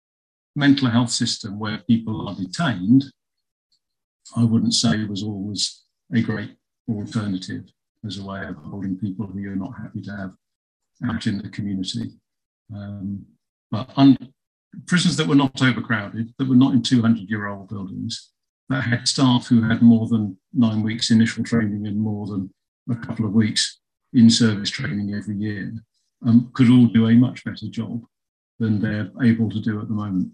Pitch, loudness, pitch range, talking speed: 110 Hz, -21 LUFS, 105-120 Hz, 165 wpm